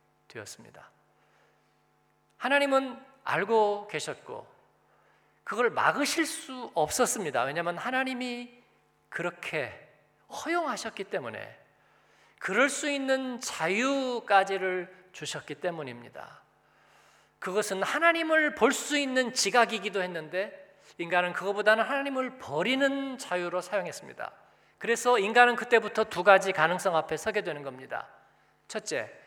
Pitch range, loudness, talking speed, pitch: 185-260 Hz, -28 LUFS, 270 characters per minute, 220 Hz